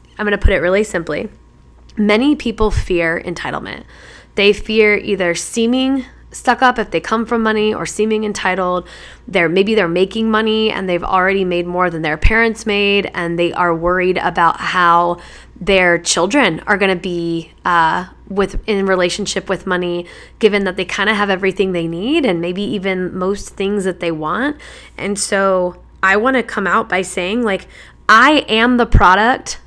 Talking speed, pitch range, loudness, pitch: 175 wpm, 180-215 Hz, -15 LUFS, 195 Hz